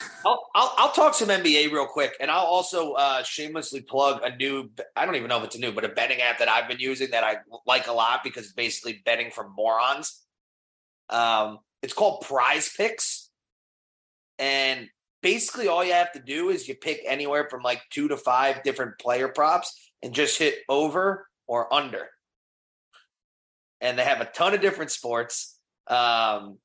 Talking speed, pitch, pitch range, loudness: 180 wpm, 135 Hz, 115-150 Hz, -24 LUFS